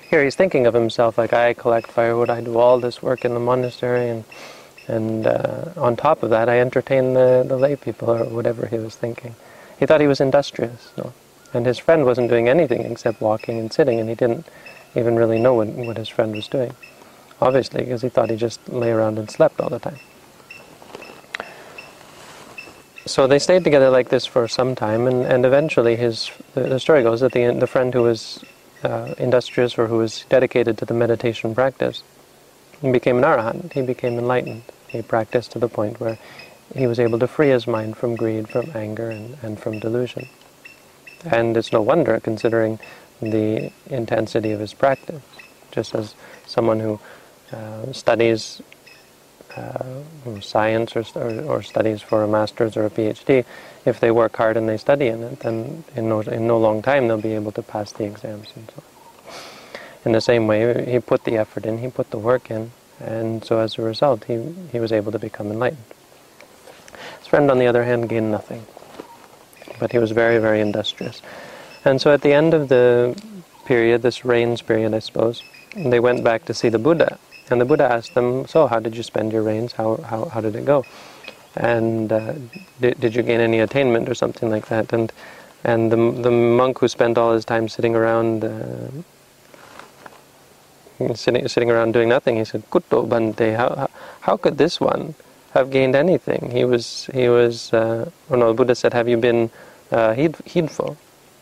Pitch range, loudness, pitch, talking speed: 110-125 Hz, -19 LUFS, 115 Hz, 195 wpm